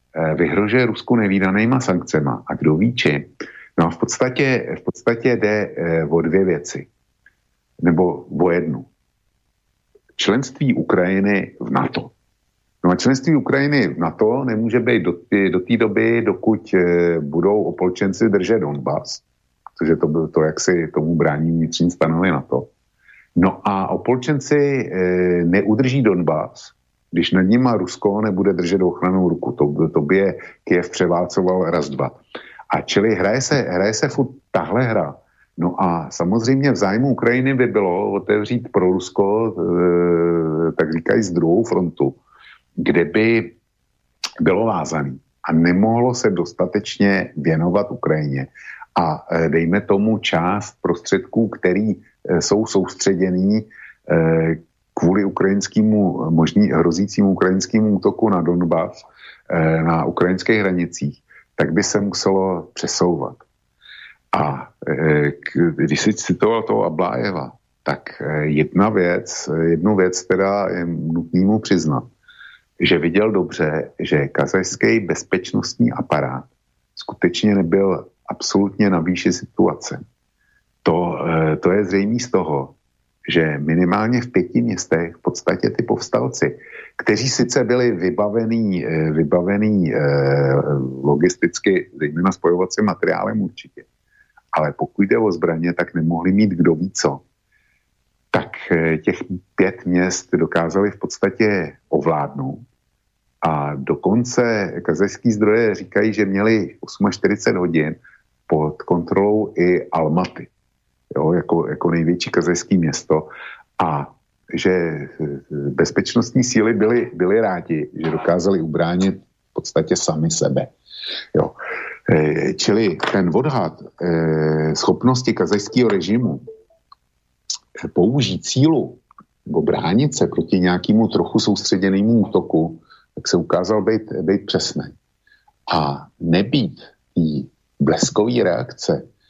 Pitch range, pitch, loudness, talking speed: 80-110 Hz, 90 Hz, -18 LUFS, 115 wpm